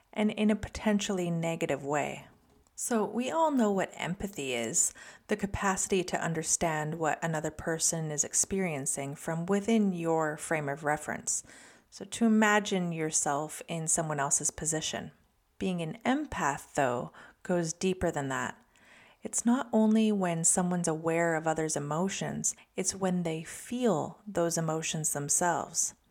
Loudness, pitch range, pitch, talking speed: -30 LUFS, 155-200 Hz, 170 Hz, 140 wpm